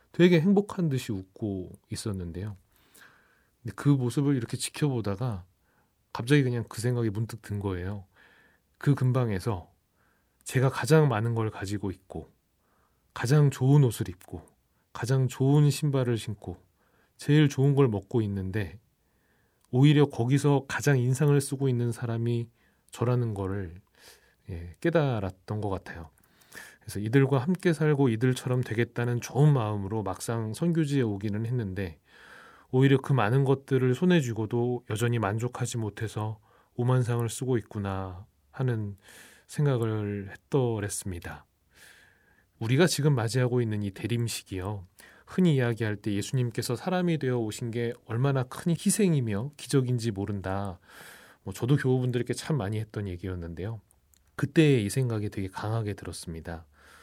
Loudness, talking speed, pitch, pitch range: -28 LUFS, 295 characters per minute, 115 Hz, 100-135 Hz